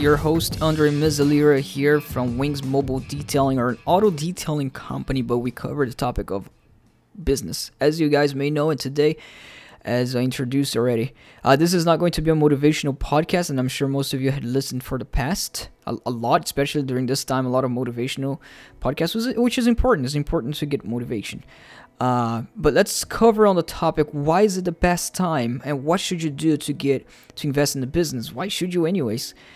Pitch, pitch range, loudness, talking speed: 140 Hz, 130-160 Hz, -22 LUFS, 205 wpm